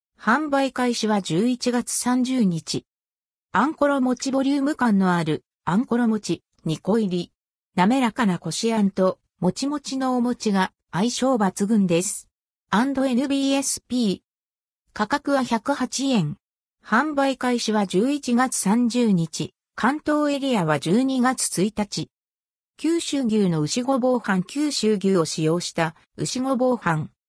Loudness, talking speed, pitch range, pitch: -23 LUFS, 210 characters per minute, 180-260 Hz, 225 Hz